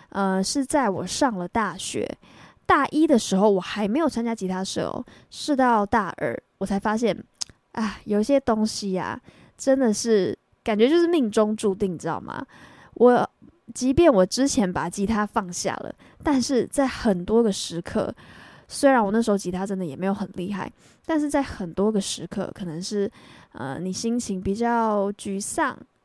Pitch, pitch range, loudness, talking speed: 210 Hz, 190-245 Hz, -24 LUFS, 245 characters per minute